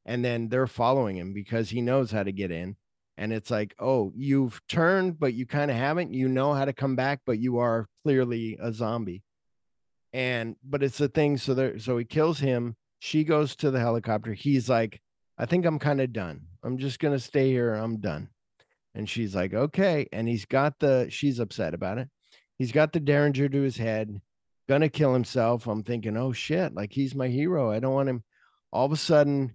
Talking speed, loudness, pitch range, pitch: 215 wpm, -27 LUFS, 110-140 Hz, 125 Hz